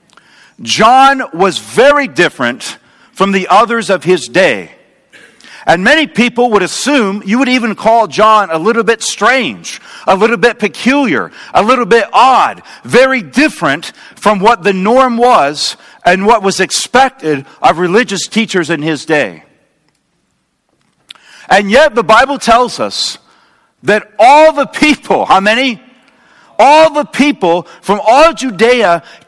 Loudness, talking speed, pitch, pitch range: -9 LUFS, 135 wpm, 230 Hz, 195-265 Hz